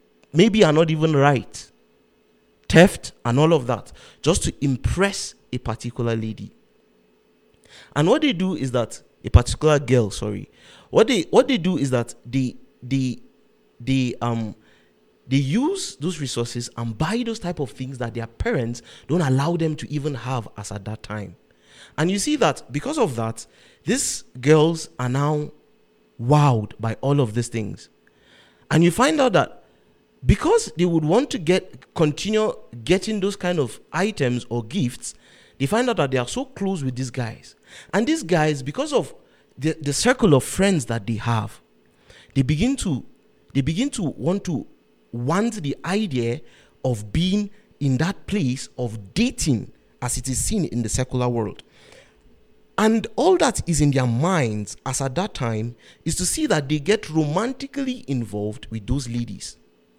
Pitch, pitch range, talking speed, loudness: 135 Hz, 120-175 Hz, 170 wpm, -22 LUFS